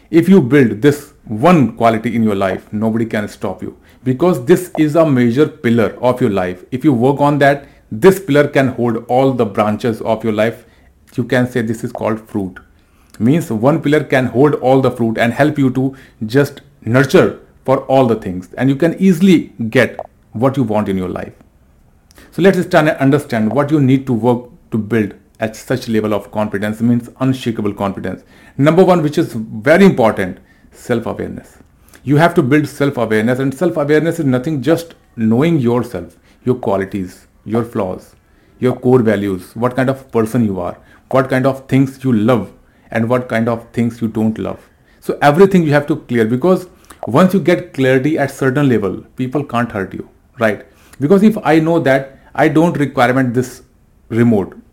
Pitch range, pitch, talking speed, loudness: 110-145 Hz, 125 Hz, 185 wpm, -14 LUFS